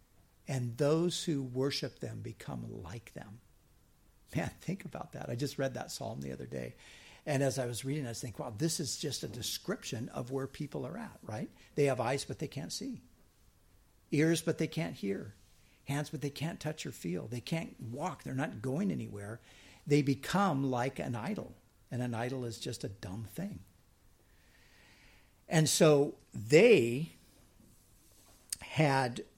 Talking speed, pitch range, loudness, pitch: 170 wpm, 100-150 Hz, -34 LUFS, 130 Hz